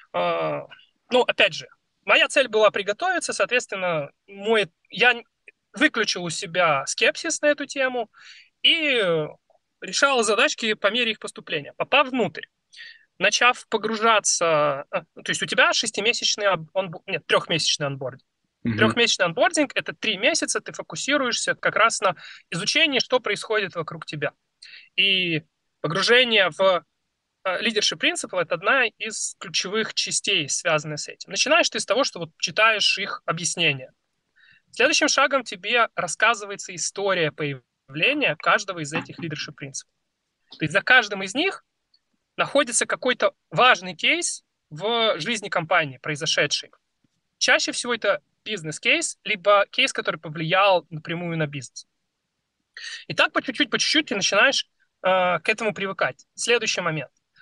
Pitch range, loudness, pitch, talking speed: 175-260 Hz, -22 LUFS, 215 Hz, 130 wpm